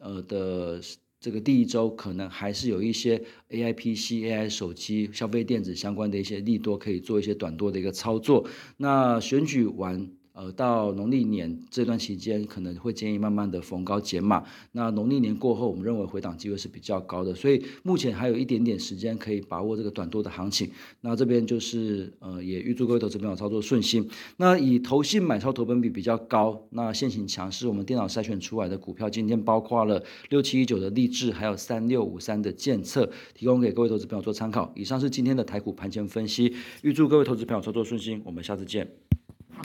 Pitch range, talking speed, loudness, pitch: 100-120 Hz, 335 characters per minute, -27 LUFS, 110 Hz